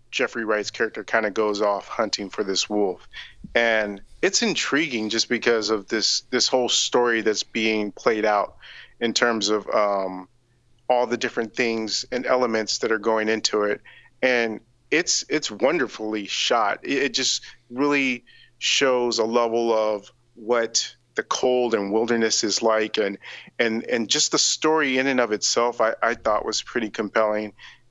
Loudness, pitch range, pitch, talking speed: -22 LUFS, 110-120 Hz, 115 Hz, 165 wpm